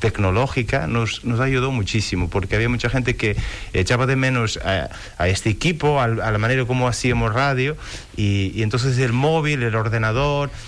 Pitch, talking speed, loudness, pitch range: 115 Hz, 175 wpm, -20 LUFS, 105-130 Hz